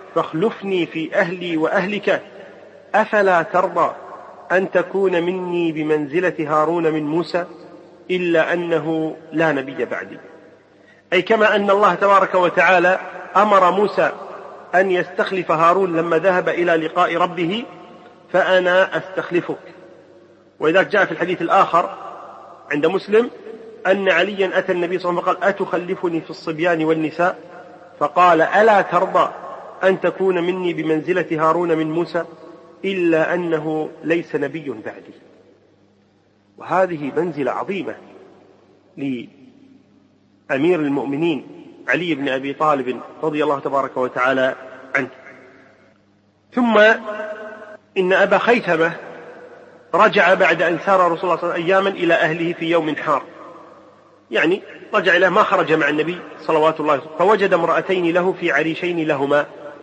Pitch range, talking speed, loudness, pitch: 160-185 Hz, 120 wpm, -18 LUFS, 175 Hz